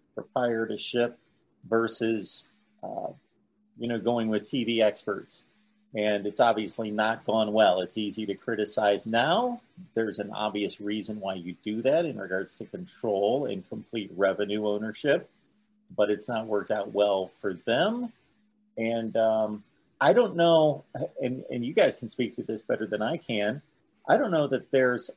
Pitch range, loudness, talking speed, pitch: 105-120 Hz, -28 LUFS, 155 wpm, 110 Hz